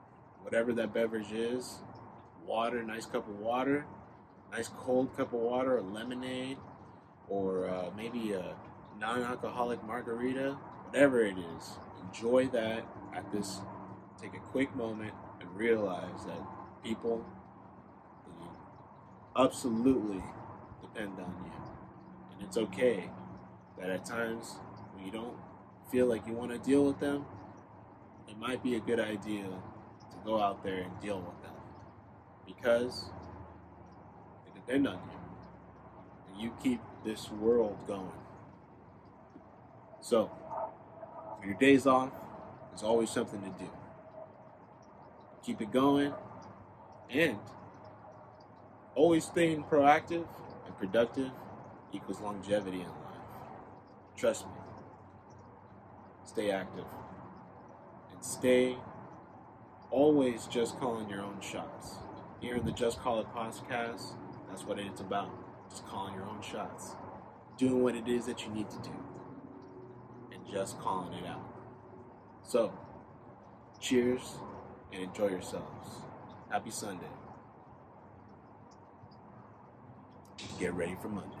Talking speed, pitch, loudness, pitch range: 115 wpm, 110 Hz, -34 LUFS, 95-125 Hz